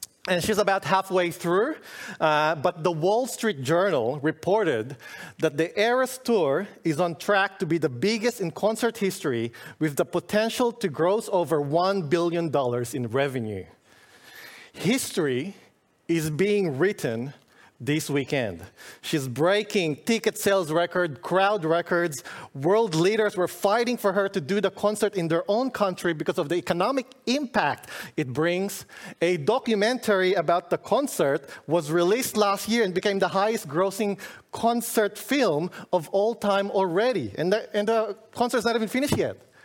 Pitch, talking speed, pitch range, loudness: 190 Hz, 150 wpm, 165-210 Hz, -25 LUFS